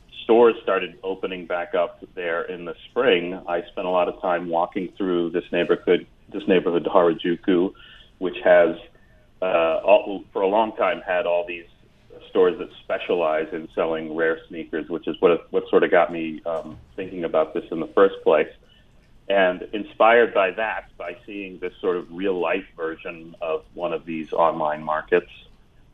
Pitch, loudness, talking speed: 90 Hz, -22 LUFS, 170 wpm